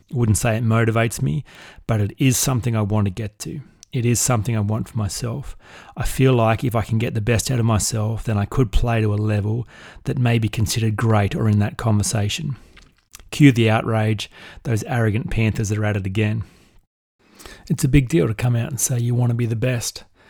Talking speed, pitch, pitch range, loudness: 220 wpm, 115 Hz, 110-125 Hz, -20 LUFS